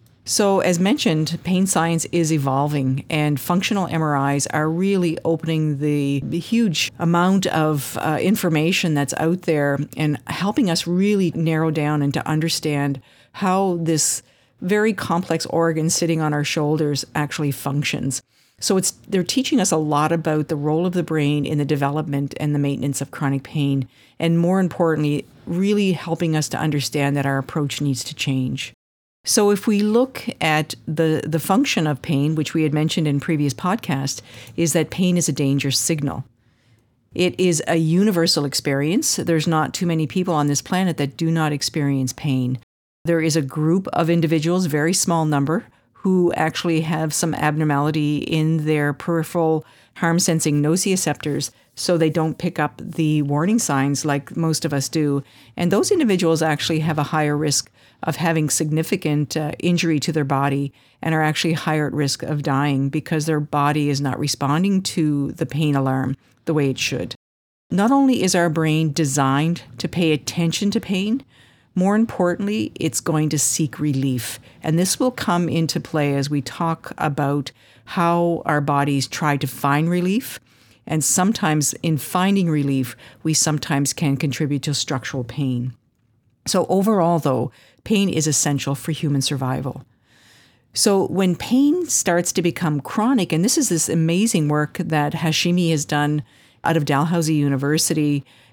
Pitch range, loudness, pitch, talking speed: 140-170 Hz, -20 LUFS, 155 Hz, 165 wpm